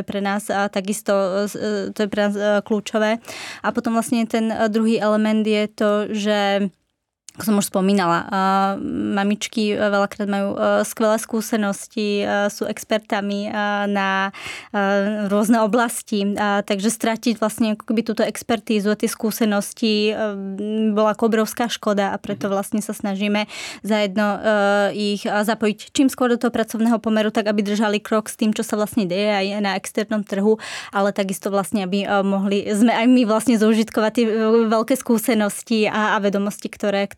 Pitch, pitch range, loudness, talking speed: 210 Hz, 205-225 Hz, -20 LUFS, 145 wpm